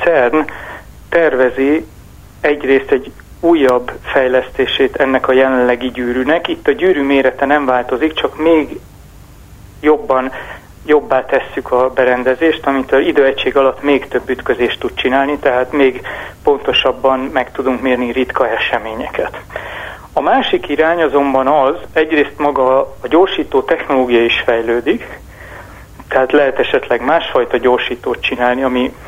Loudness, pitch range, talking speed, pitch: -14 LUFS, 125-145 Hz, 120 wpm, 130 Hz